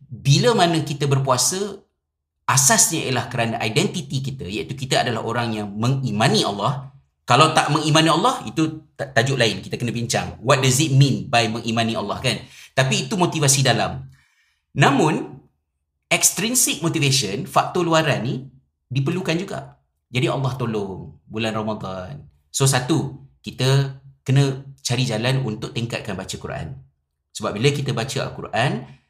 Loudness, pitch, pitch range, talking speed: -20 LUFS, 135 Hz, 115-150 Hz, 135 wpm